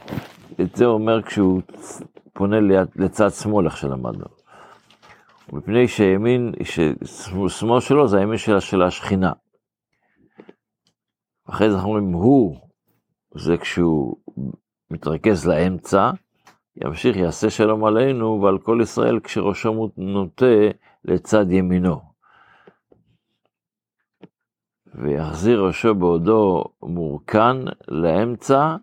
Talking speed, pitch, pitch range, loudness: 90 wpm, 100 Hz, 90-110 Hz, -19 LUFS